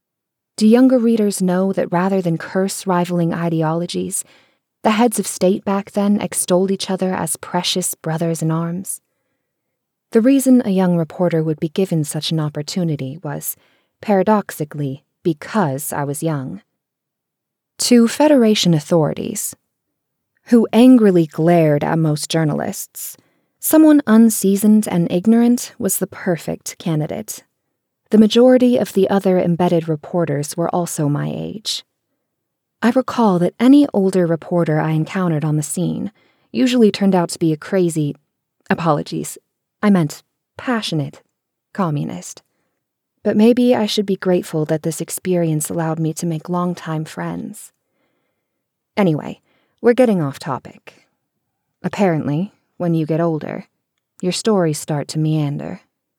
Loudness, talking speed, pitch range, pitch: -17 LUFS, 130 wpm, 160-210 Hz, 180 Hz